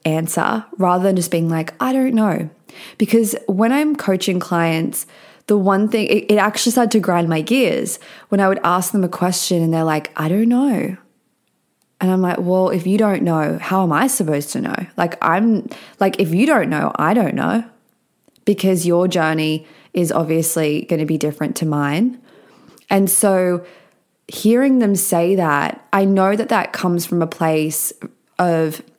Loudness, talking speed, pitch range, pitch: -17 LUFS, 180 wpm, 165-220 Hz, 185 Hz